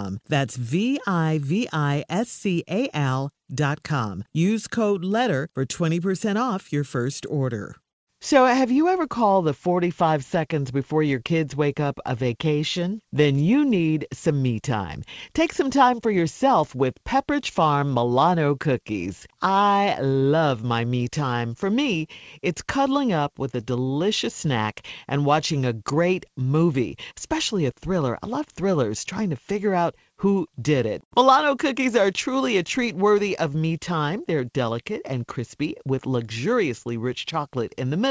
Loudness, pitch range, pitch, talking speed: -23 LUFS, 135-200 Hz, 155 Hz, 165 wpm